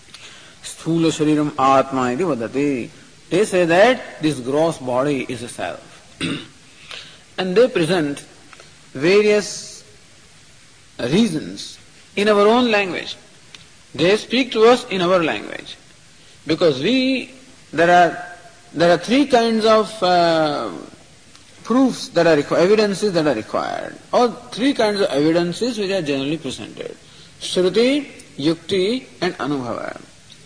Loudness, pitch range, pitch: -18 LUFS, 155-225 Hz, 180 Hz